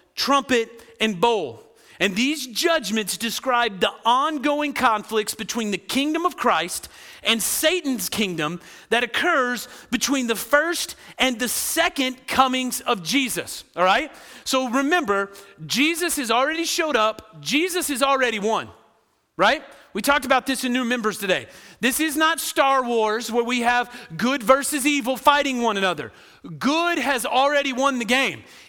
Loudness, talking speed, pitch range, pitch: -21 LUFS, 150 wpm, 220-285 Hz, 250 Hz